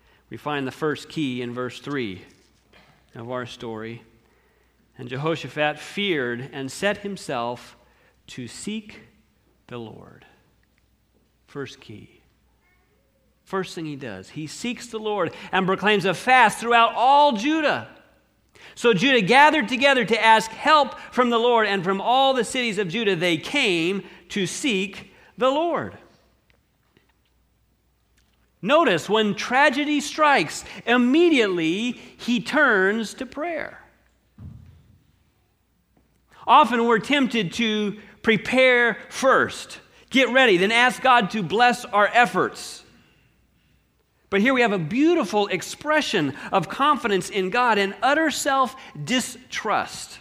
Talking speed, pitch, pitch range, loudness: 120 wpm, 215 Hz, 180-255 Hz, -21 LUFS